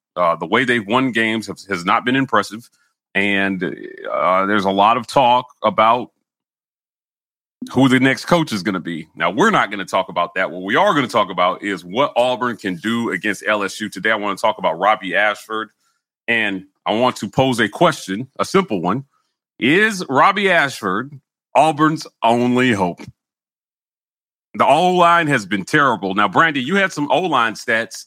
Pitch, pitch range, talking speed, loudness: 115 Hz, 100-130 Hz, 185 wpm, -17 LUFS